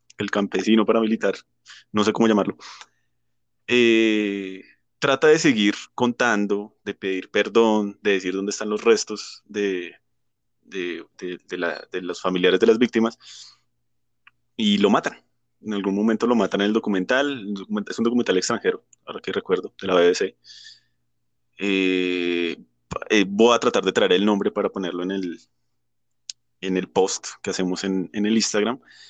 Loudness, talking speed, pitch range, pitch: -22 LUFS, 155 wpm, 90-110 Hz, 100 Hz